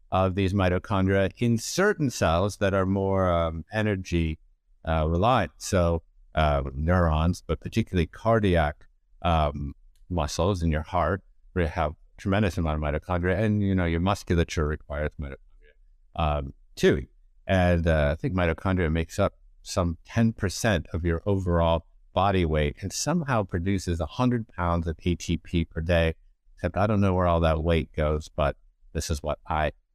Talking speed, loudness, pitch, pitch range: 160 wpm, -26 LUFS, 85 Hz, 80-95 Hz